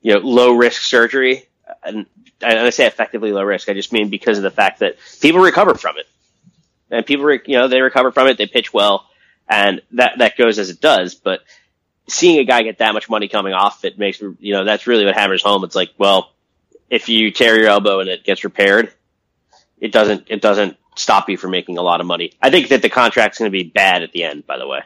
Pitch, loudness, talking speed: 125 Hz, -14 LUFS, 245 wpm